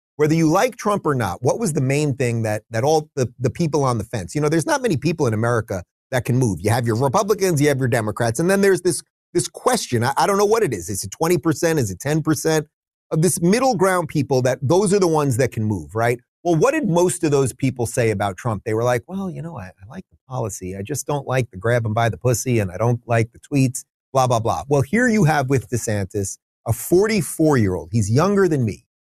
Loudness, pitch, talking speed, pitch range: -20 LUFS, 135 Hz, 260 wpm, 115-165 Hz